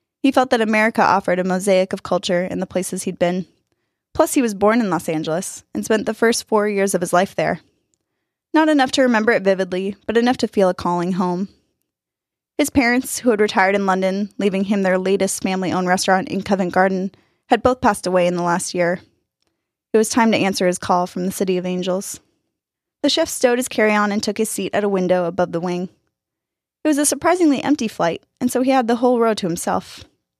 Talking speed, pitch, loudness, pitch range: 215 wpm, 195 Hz, -18 LUFS, 185-235 Hz